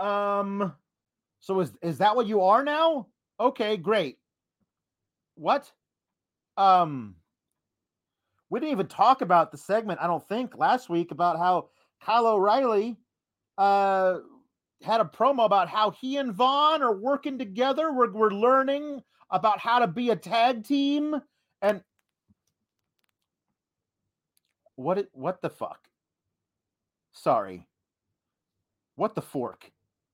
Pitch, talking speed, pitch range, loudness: 215 Hz, 120 wpm, 185-255 Hz, -25 LUFS